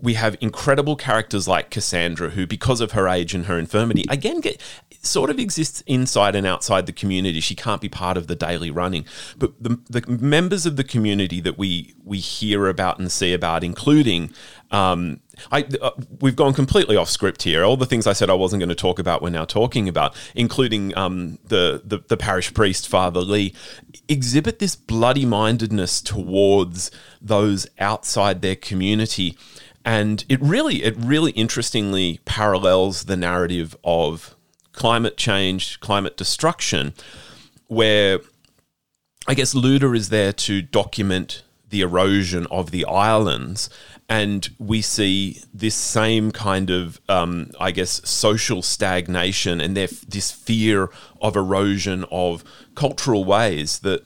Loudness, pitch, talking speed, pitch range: -20 LUFS, 100 Hz, 155 wpm, 90-115 Hz